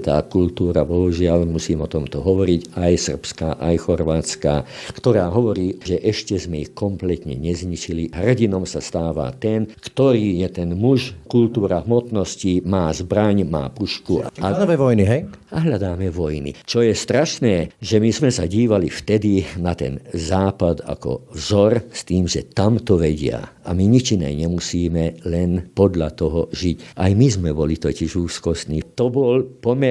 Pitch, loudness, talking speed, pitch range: 90 Hz, -20 LUFS, 155 wpm, 80-110 Hz